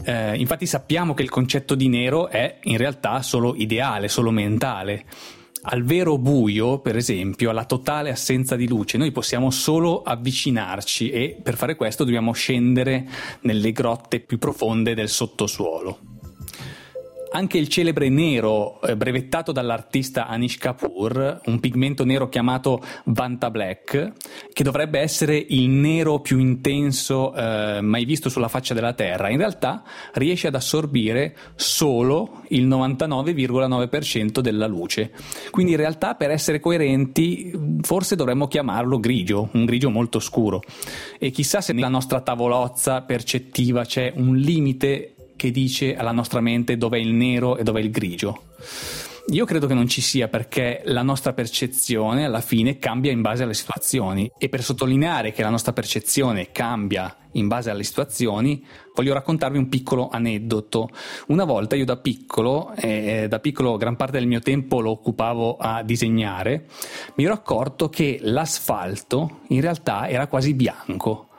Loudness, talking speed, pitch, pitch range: -22 LUFS, 150 wpm, 125 Hz, 115-140 Hz